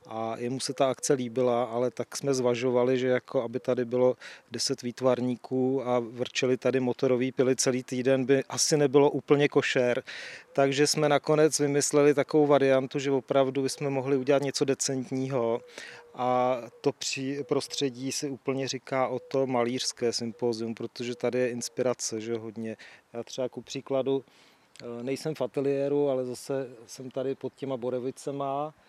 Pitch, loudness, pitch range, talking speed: 130 Hz, -28 LUFS, 125-140 Hz, 150 wpm